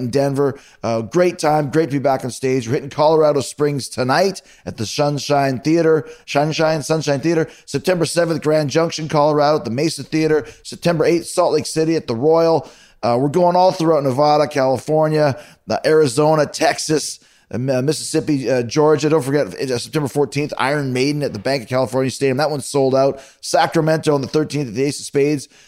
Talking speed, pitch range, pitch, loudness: 190 wpm, 135-155 Hz, 145 Hz, -18 LUFS